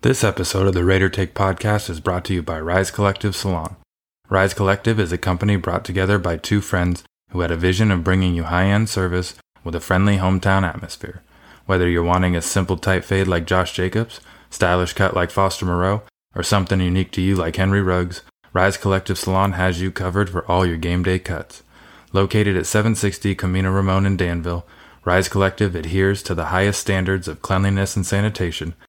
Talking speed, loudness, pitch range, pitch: 190 wpm, -20 LUFS, 90-100 Hz, 95 Hz